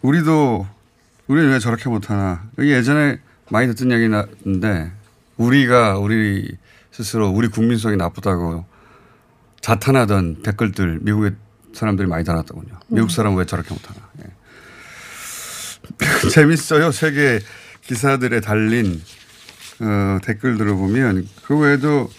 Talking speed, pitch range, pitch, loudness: 270 characters per minute, 100-125 Hz, 110 Hz, -18 LUFS